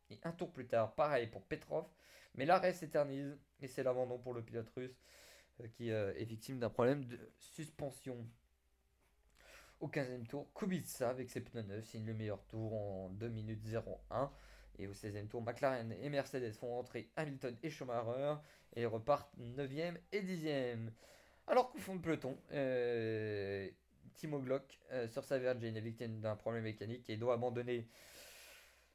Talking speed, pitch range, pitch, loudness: 170 wpm, 110-140 Hz, 120 Hz, -42 LUFS